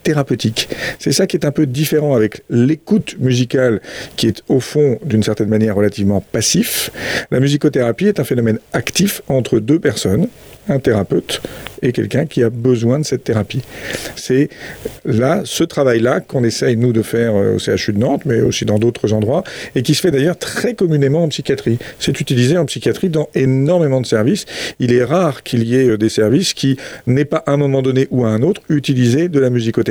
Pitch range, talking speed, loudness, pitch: 115-150 Hz, 195 wpm, -15 LUFS, 130 Hz